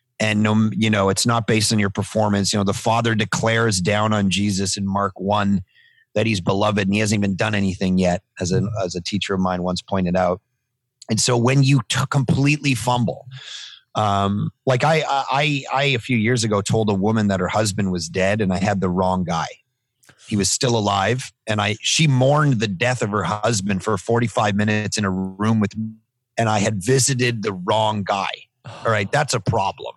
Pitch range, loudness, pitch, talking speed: 100-125 Hz, -20 LUFS, 110 Hz, 210 wpm